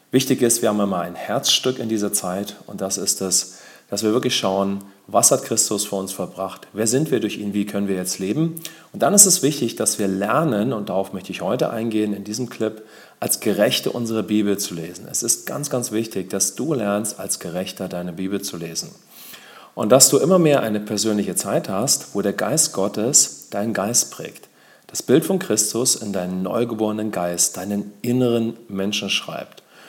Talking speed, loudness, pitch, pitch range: 200 wpm, -20 LUFS, 105 Hz, 95-115 Hz